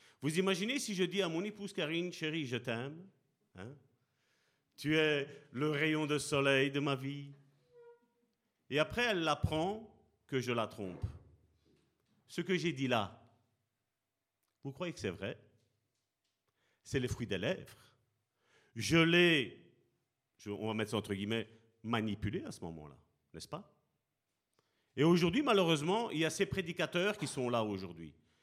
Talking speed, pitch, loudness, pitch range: 150 wpm, 140 Hz, -35 LUFS, 110-170 Hz